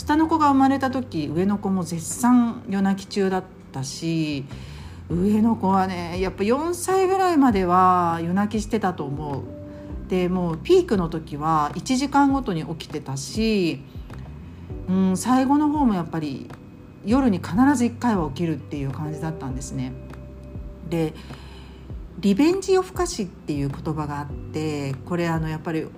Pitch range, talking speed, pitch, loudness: 145-220 Hz, 290 characters per minute, 175 Hz, -23 LUFS